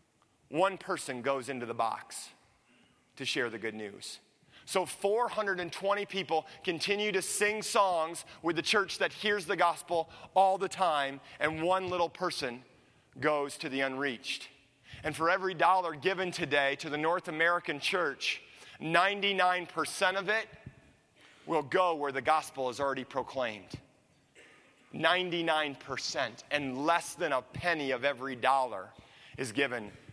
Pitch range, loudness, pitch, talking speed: 135-185 Hz, -31 LUFS, 160 Hz, 135 wpm